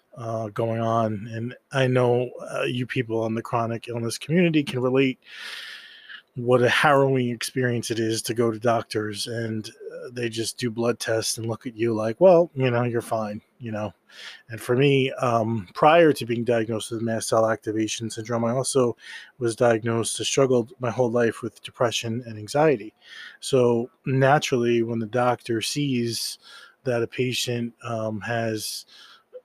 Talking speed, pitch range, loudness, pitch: 165 wpm, 115-130 Hz, -24 LUFS, 120 Hz